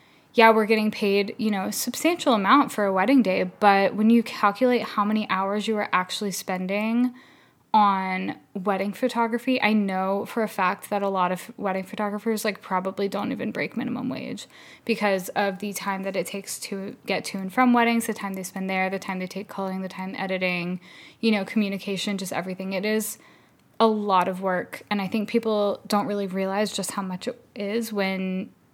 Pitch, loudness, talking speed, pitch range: 205 Hz, -24 LUFS, 200 wpm, 190-225 Hz